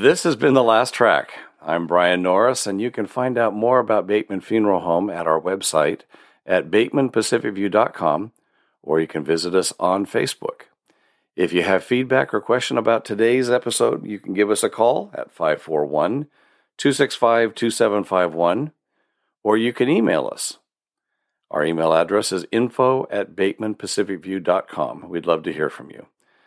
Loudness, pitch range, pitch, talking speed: -20 LUFS, 90-120 Hz, 105 Hz, 150 wpm